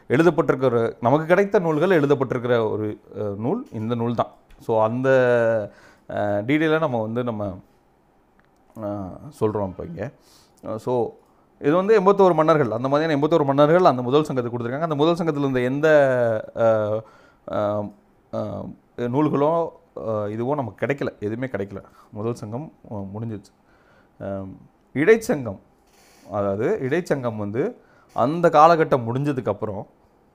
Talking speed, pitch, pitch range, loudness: 105 wpm, 125 Hz, 110-150 Hz, -21 LUFS